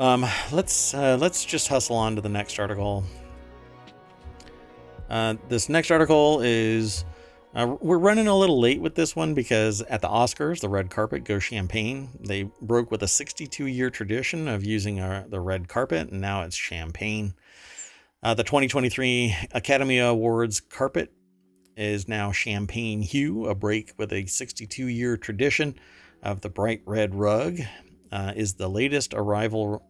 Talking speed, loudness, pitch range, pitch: 155 wpm, -25 LUFS, 100-125 Hz, 110 Hz